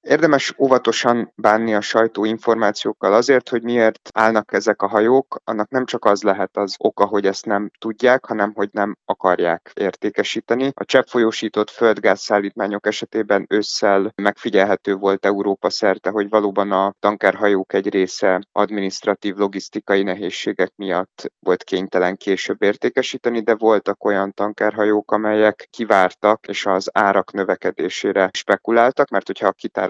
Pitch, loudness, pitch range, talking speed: 105 Hz, -18 LUFS, 100-115 Hz, 135 wpm